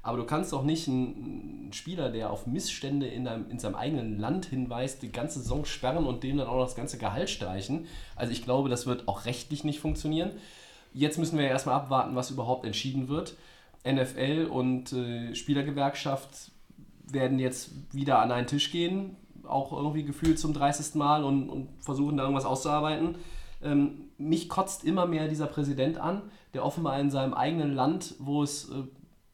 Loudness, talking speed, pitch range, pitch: -31 LUFS, 180 wpm, 130-155 Hz, 140 Hz